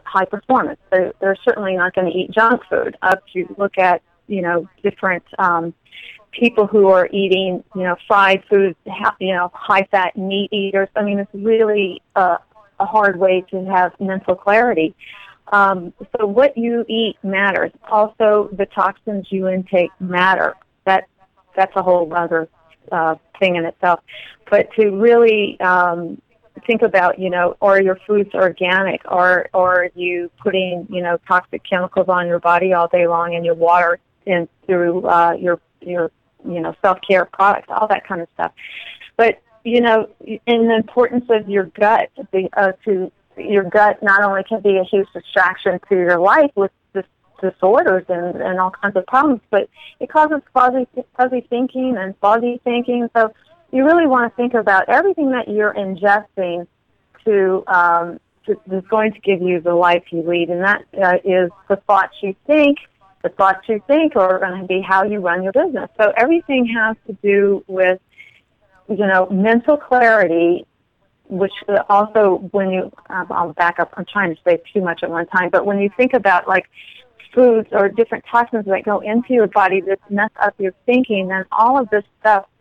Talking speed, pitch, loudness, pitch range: 180 wpm, 195 Hz, -16 LUFS, 180-220 Hz